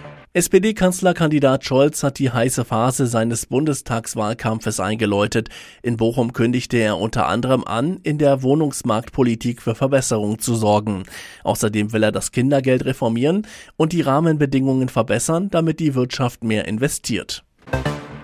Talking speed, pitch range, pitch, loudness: 125 wpm, 110-140 Hz, 125 Hz, -19 LUFS